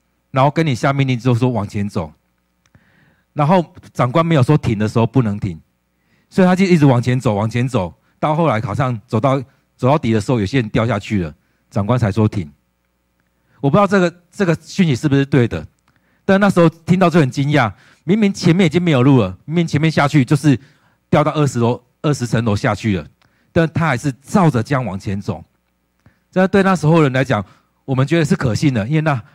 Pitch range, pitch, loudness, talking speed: 105-160 Hz, 130 Hz, -16 LUFS, 305 characters per minute